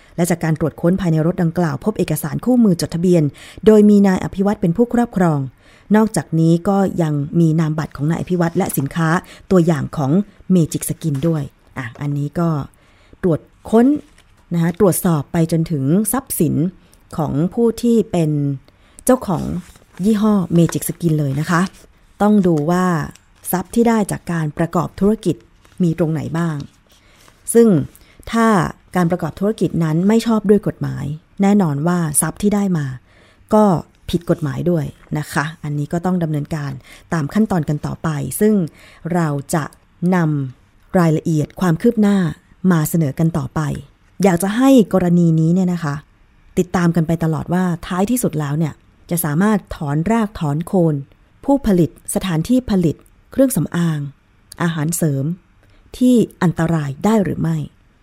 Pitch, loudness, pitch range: 170 Hz, -17 LUFS, 150-190 Hz